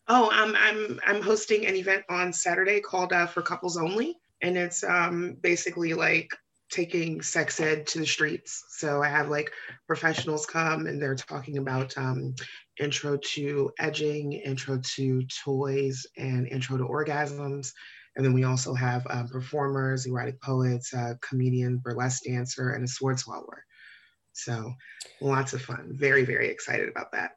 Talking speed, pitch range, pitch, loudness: 160 wpm, 130-170 Hz, 145 Hz, -27 LUFS